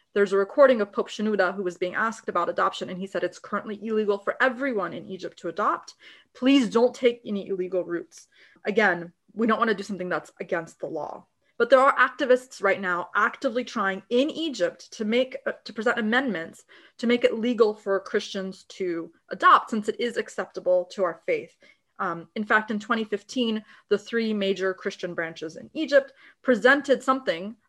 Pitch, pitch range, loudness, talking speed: 215 Hz, 190-245 Hz, -25 LUFS, 185 wpm